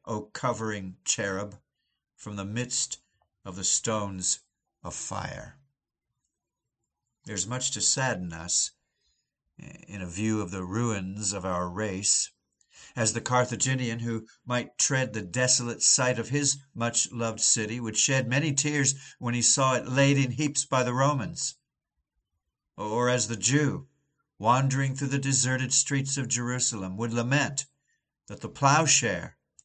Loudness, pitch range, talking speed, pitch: -26 LUFS, 105-135 Hz, 140 wpm, 120 Hz